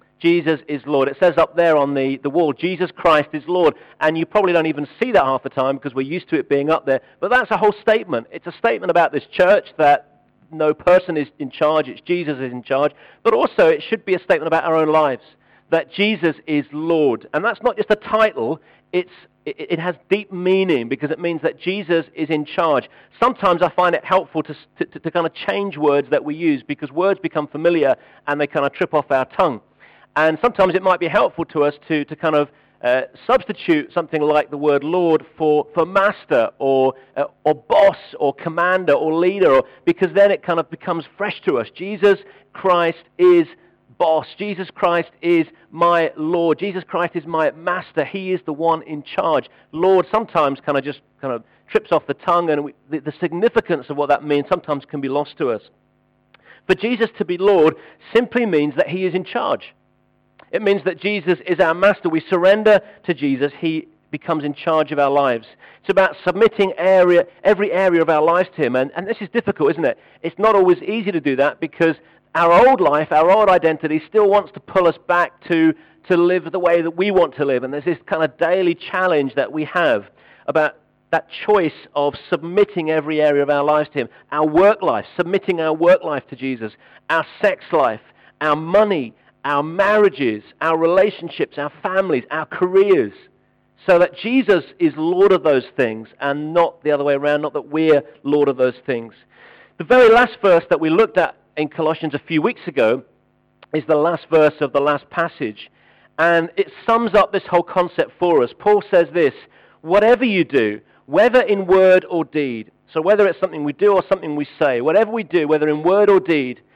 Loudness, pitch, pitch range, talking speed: -18 LUFS, 170 Hz, 150-190 Hz, 210 wpm